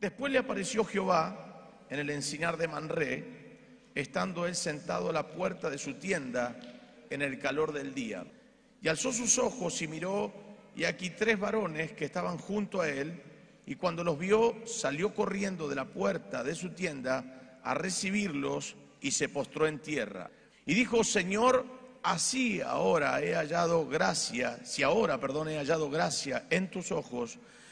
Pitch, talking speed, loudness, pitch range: 180 Hz, 160 wpm, -32 LUFS, 150-210 Hz